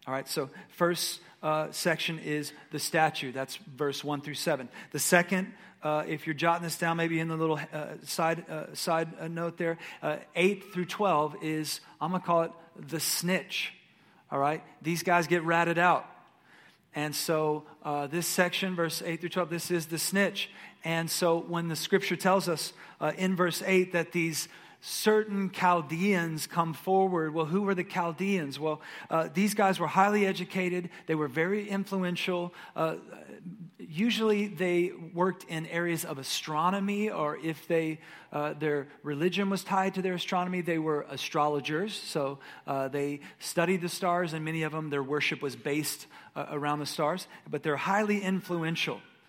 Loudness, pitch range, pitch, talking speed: -30 LUFS, 155-185 Hz, 170 Hz, 170 wpm